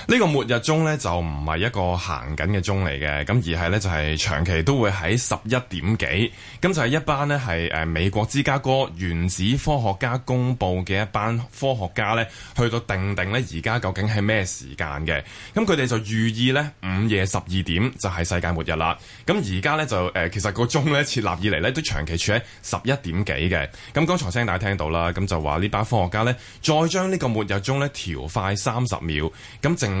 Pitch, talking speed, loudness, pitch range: 105 Hz, 310 characters per minute, -23 LUFS, 90-125 Hz